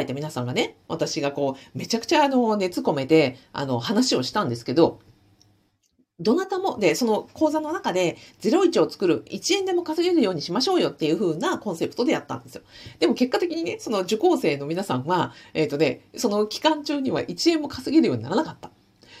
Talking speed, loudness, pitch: 400 characters per minute, -23 LUFS, 215 Hz